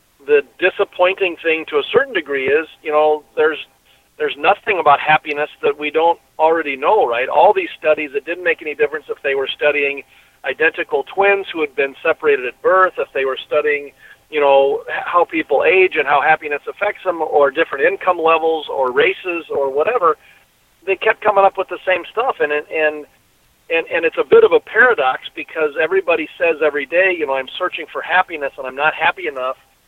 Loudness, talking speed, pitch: -16 LUFS, 195 wpm, 170 Hz